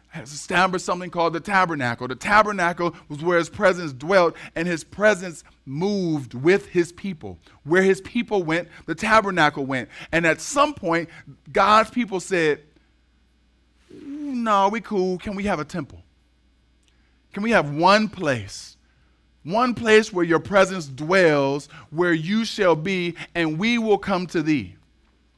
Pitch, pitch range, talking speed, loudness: 170 Hz, 140-195 Hz, 150 wpm, -21 LUFS